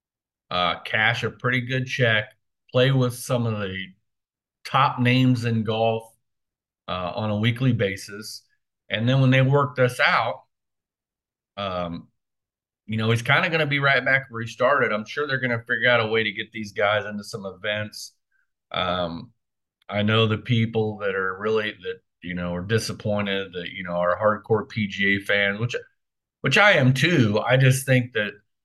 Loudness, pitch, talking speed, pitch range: -22 LUFS, 110 Hz, 180 wpm, 105-125 Hz